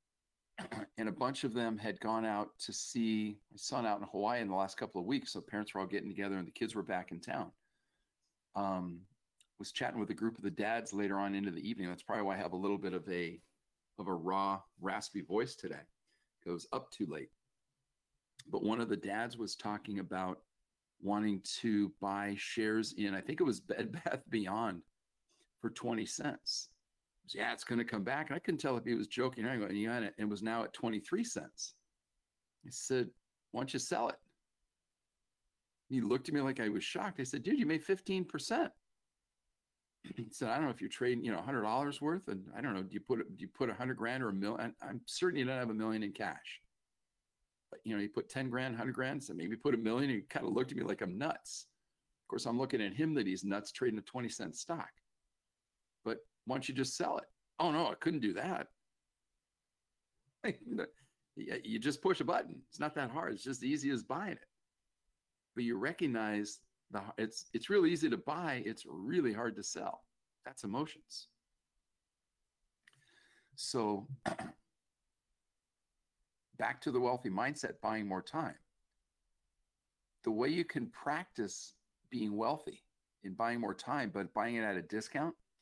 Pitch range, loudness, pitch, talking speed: 95-125 Hz, -38 LUFS, 105 Hz, 200 wpm